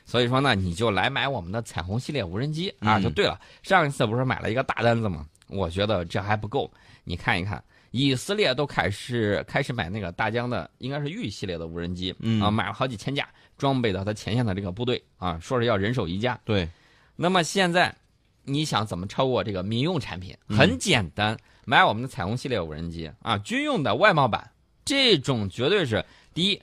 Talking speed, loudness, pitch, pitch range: 320 characters per minute, -25 LUFS, 115 Hz, 95-135 Hz